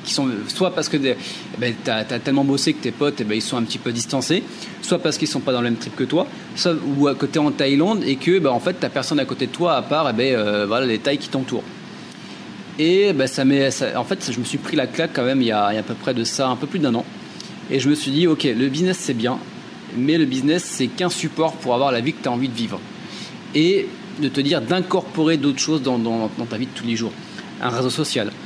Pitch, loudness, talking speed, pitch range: 140 Hz, -20 LUFS, 290 wpm, 125-160 Hz